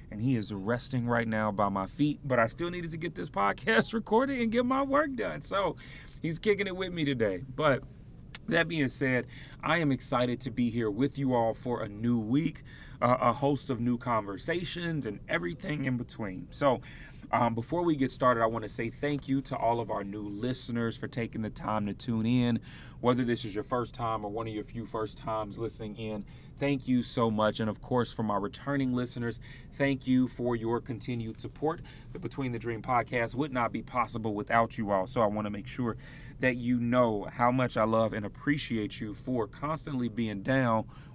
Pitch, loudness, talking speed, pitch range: 120 Hz, -31 LUFS, 210 wpm, 115-140 Hz